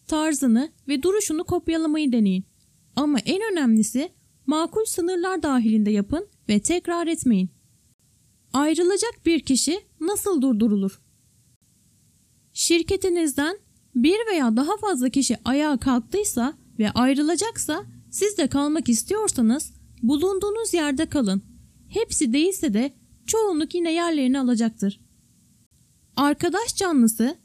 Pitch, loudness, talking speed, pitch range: 295 Hz, -23 LUFS, 100 wpm, 240-350 Hz